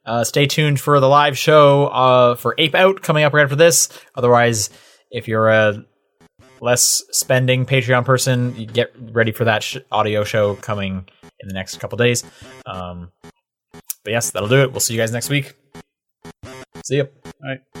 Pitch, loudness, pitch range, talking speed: 120 Hz, -16 LUFS, 105-135 Hz, 180 wpm